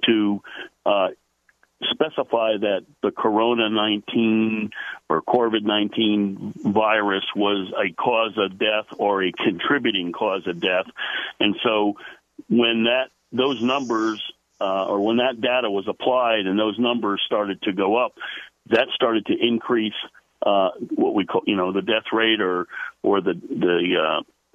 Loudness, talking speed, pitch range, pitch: -22 LUFS, 145 wpm, 100-115 Hz, 110 Hz